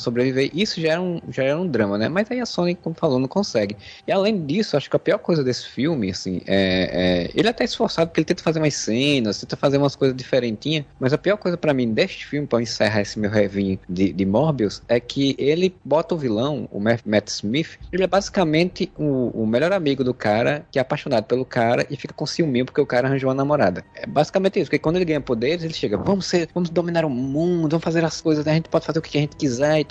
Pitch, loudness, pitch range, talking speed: 145 Hz, -21 LUFS, 120-165 Hz, 255 wpm